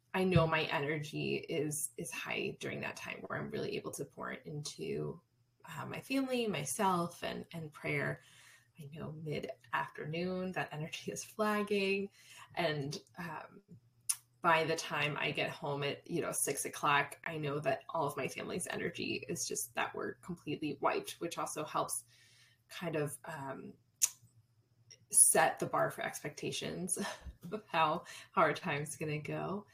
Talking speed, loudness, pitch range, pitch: 155 wpm, -36 LUFS, 135-175 Hz, 155 Hz